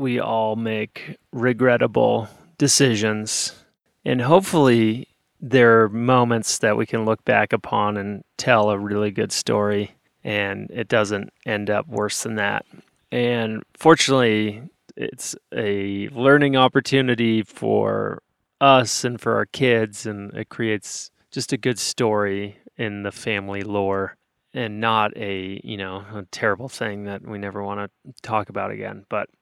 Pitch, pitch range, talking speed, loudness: 110 Hz, 105-125 Hz, 145 wpm, -21 LUFS